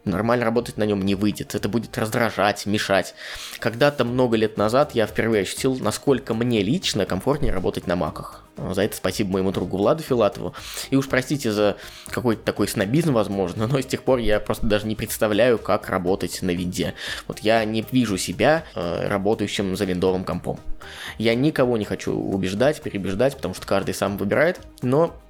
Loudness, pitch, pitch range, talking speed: -22 LUFS, 105 Hz, 95-120 Hz, 175 wpm